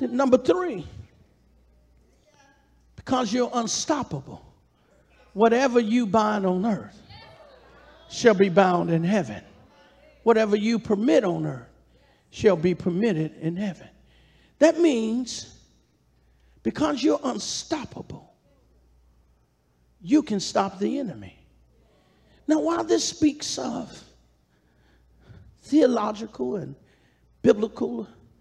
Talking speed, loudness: 90 wpm, -24 LUFS